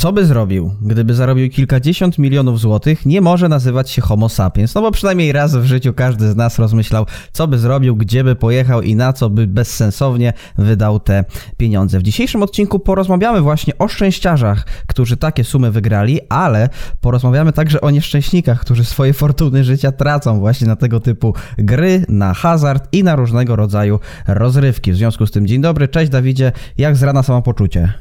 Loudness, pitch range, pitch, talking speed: -13 LUFS, 110-145 Hz, 125 Hz, 180 wpm